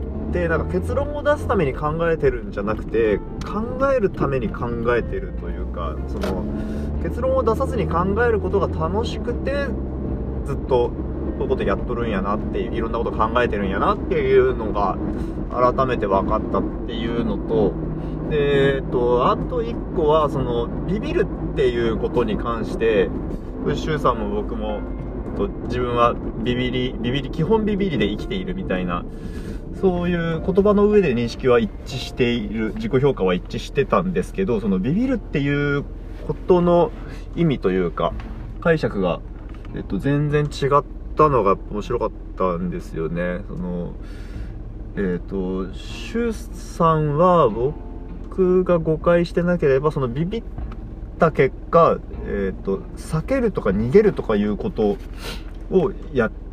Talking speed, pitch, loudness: 300 characters per minute, 125 Hz, -21 LUFS